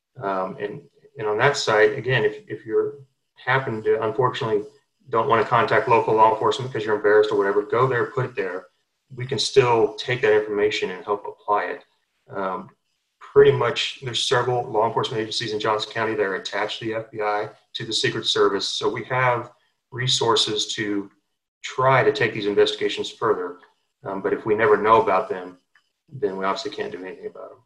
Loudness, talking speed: -22 LUFS, 190 wpm